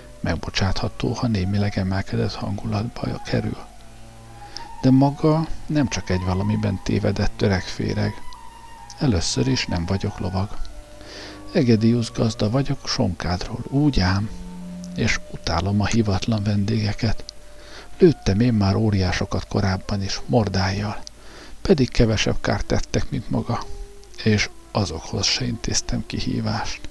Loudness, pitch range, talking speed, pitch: -22 LUFS, 95-115 Hz, 105 wpm, 105 Hz